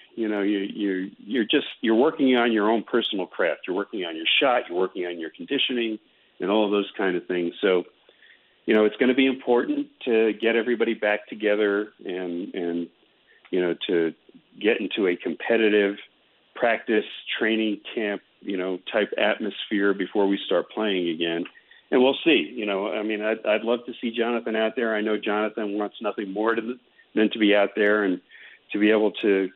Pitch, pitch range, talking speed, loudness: 105 Hz, 100-115 Hz, 195 wpm, -24 LUFS